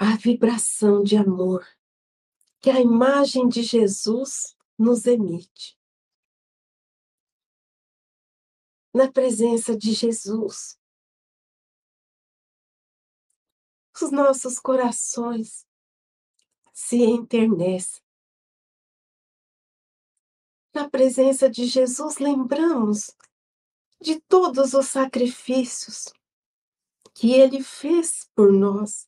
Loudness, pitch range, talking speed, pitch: -21 LUFS, 220-270 Hz, 70 wpm, 245 Hz